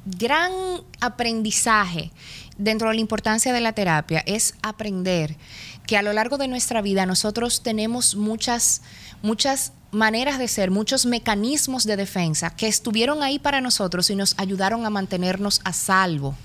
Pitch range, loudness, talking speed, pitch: 190-240 Hz, -21 LUFS, 150 wpm, 215 Hz